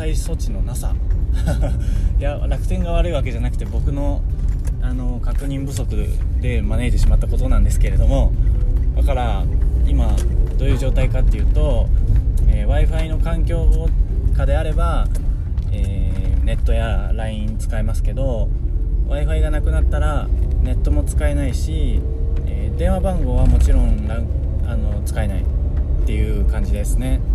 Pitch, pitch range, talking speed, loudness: 75 Hz, 70-85 Hz, 295 characters per minute, -20 LUFS